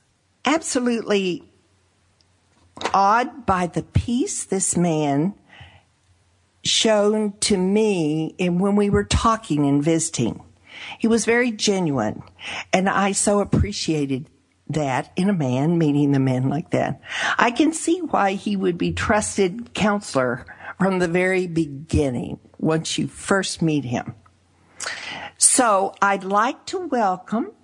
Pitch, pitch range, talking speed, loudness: 180 Hz, 135-205 Hz, 125 wpm, -21 LUFS